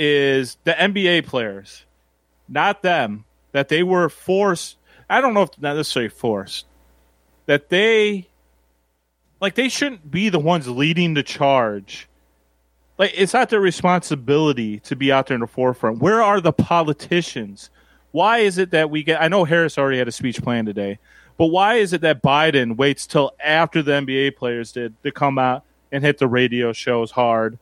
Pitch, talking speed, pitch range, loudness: 140 Hz, 175 wpm, 115-175 Hz, -19 LUFS